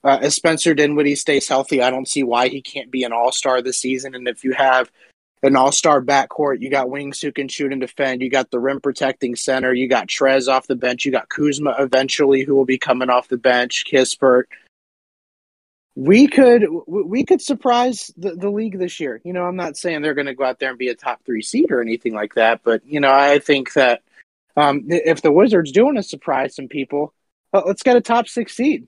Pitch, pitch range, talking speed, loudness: 140 Hz, 130-165 Hz, 225 wpm, -17 LUFS